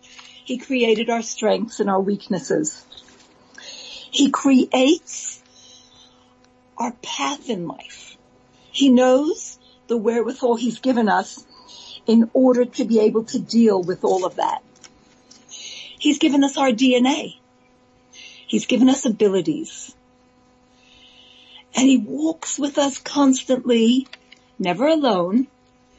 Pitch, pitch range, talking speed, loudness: 250 Hz, 215-265 Hz, 110 wpm, -19 LUFS